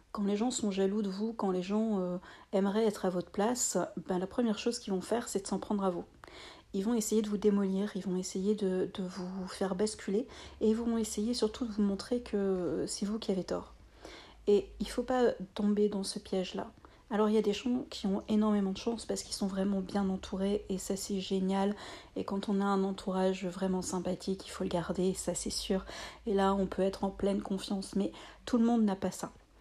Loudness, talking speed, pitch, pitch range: -33 LUFS, 235 wpm, 200 Hz, 190-215 Hz